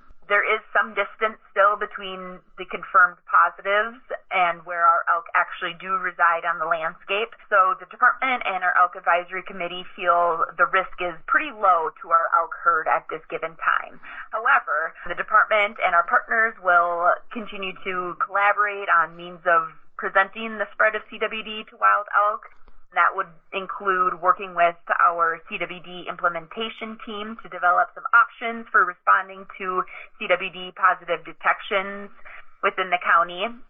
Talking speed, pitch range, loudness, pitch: 150 wpm, 175-210 Hz, -22 LUFS, 185 Hz